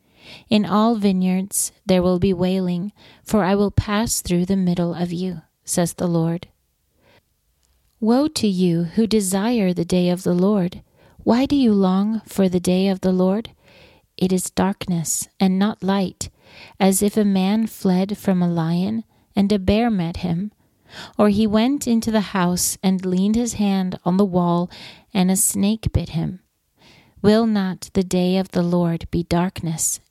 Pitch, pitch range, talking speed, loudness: 190 Hz, 180-210 Hz, 170 wpm, -20 LUFS